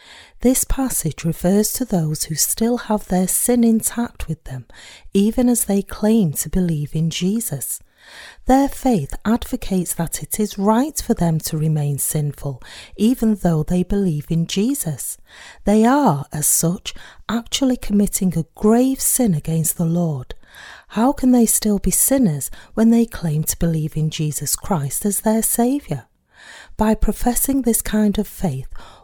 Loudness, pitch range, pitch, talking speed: -19 LUFS, 155-230 Hz, 200 Hz, 155 wpm